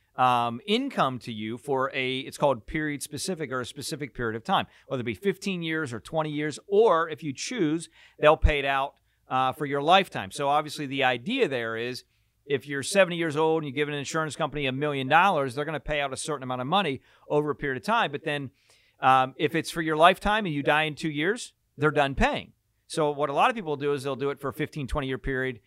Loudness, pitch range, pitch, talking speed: -26 LUFS, 130-155 Hz, 145 Hz, 245 wpm